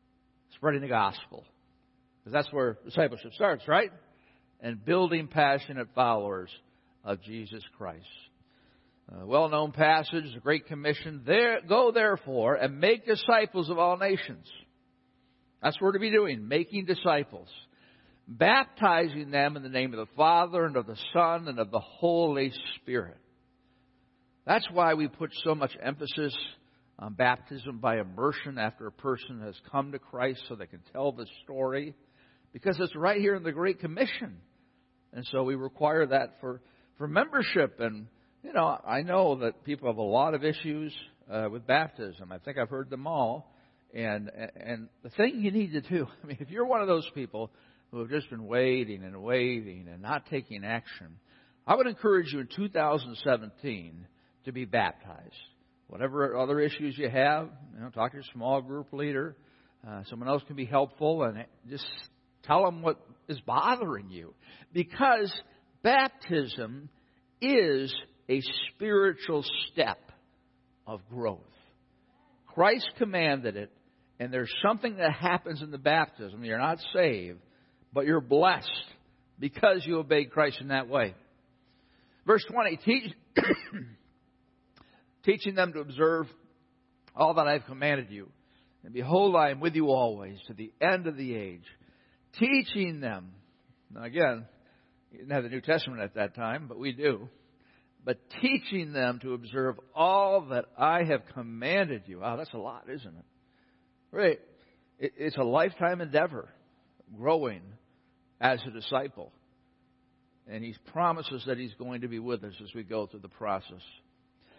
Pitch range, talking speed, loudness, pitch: 120-160 Hz, 155 wpm, -29 LUFS, 135 Hz